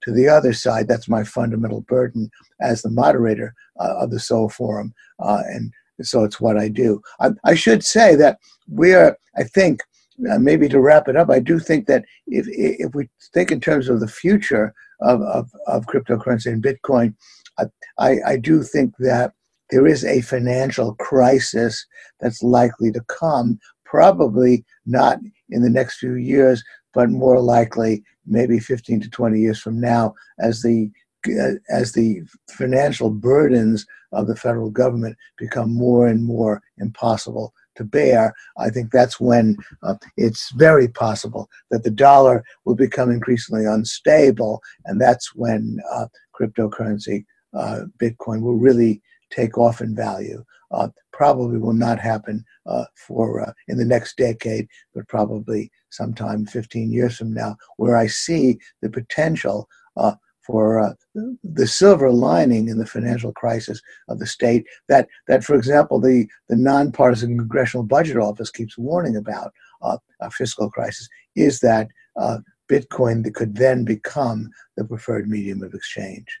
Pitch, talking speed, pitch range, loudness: 120 Hz, 160 wpm, 110-130 Hz, -18 LUFS